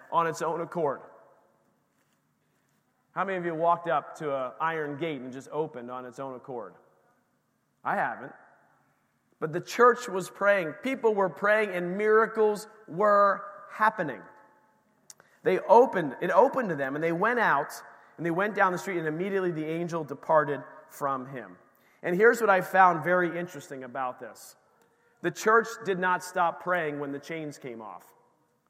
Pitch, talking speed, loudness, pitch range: 175 Hz, 165 wpm, -27 LUFS, 150-195 Hz